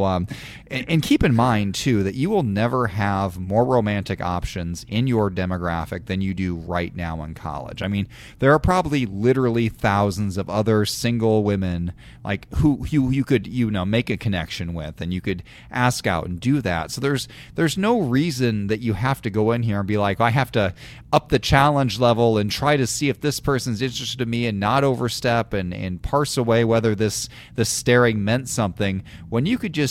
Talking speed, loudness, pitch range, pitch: 210 wpm, -22 LUFS, 100-130 Hz, 115 Hz